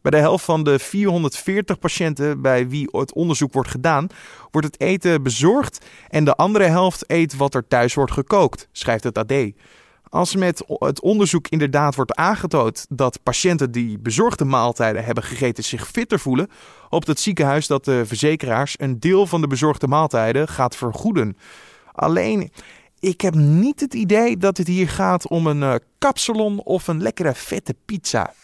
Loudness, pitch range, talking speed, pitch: -19 LUFS, 135-185 Hz, 165 wpm, 150 Hz